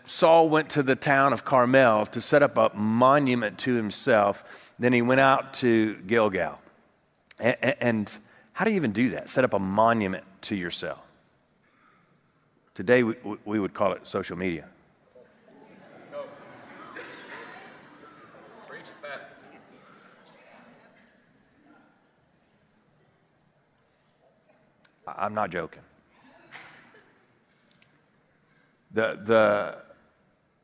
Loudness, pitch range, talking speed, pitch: -24 LUFS, 110-135 Hz, 90 wpm, 120 Hz